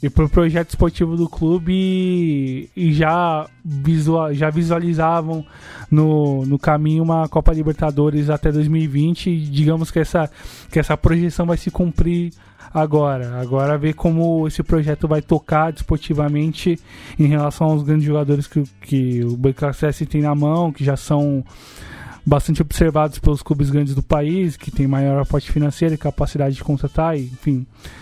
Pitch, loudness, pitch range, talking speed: 155 Hz, -18 LUFS, 145-165 Hz, 150 wpm